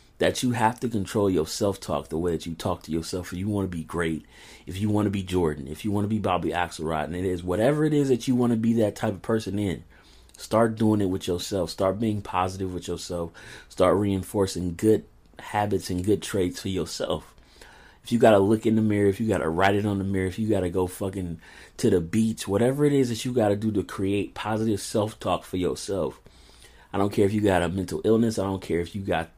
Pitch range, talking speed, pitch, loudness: 90-110 Hz, 255 wpm, 100 Hz, -25 LUFS